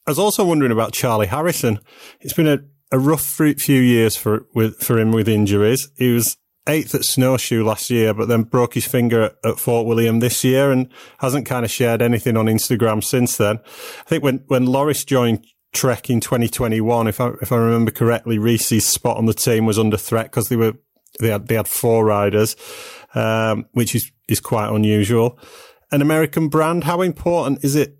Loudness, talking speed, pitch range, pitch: -18 LUFS, 200 wpm, 110-135 Hz, 120 Hz